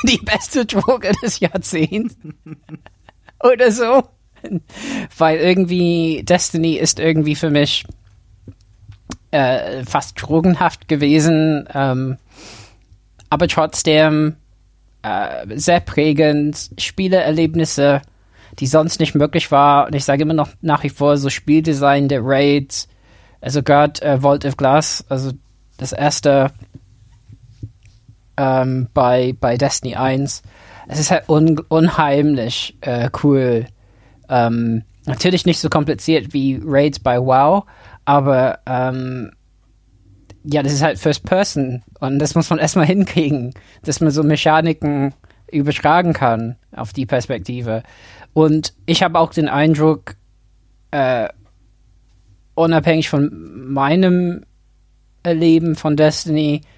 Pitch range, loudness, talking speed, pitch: 115-160 Hz, -16 LUFS, 115 wpm, 145 Hz